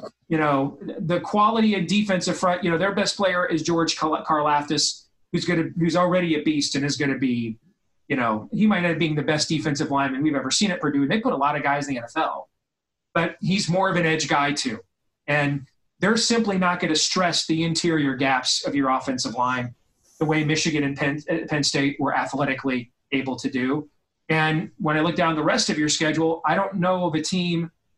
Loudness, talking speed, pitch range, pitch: -22 LUFS, 220 wpm, 145-175 Hz, 155 Hz